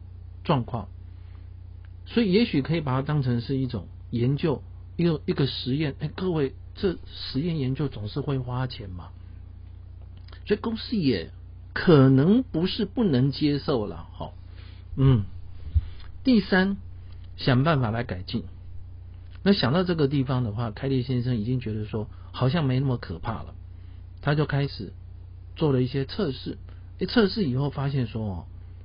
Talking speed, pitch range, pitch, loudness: 225 characters per minute, 90-140 Hz, 115 Hz, -26 LUFS